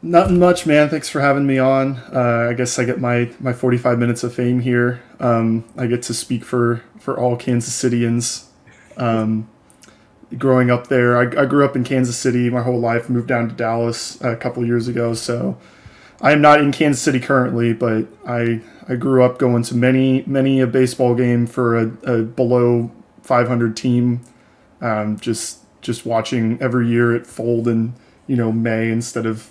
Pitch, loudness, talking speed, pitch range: 120 Hz, -18 LUFS, 190 wpm, 115-130 Hz